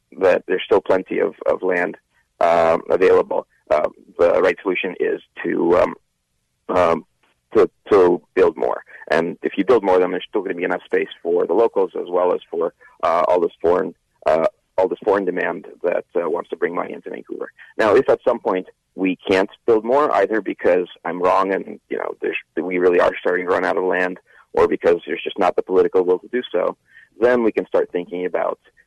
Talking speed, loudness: 210 wpm, -19 LUFS